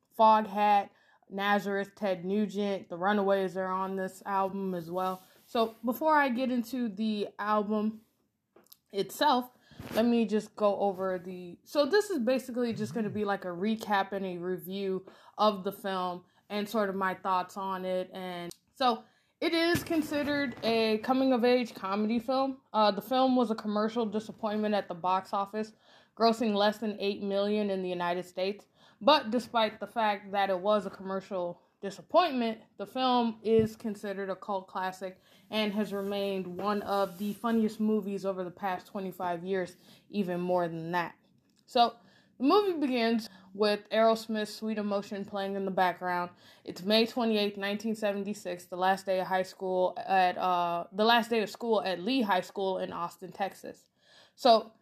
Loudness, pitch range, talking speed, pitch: -30 LUFS, 190-225 Hz, 165 wpm, 205 Hz